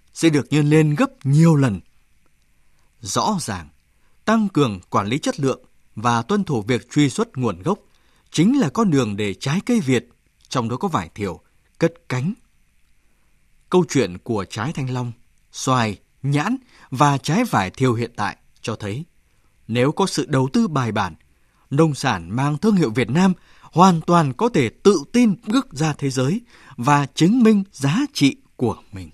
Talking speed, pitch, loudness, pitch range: 175 wpm, 140 Hz, -20 LUFS, 120-170 Hz